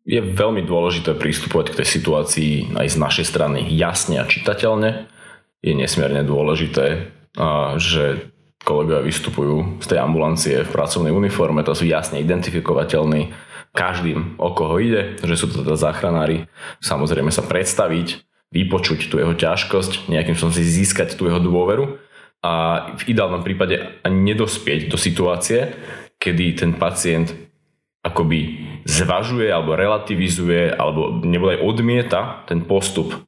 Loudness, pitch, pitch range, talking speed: -19 LUFS, 85 Hz, 80-90 Hz, 135 wpm